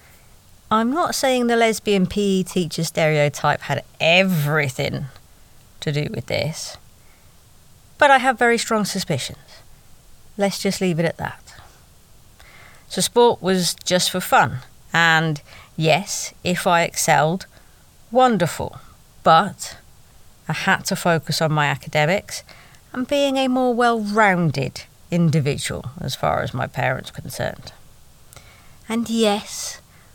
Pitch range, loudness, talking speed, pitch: 155-220 Hz, -20 LUFS, 120 wpm, 180 Hz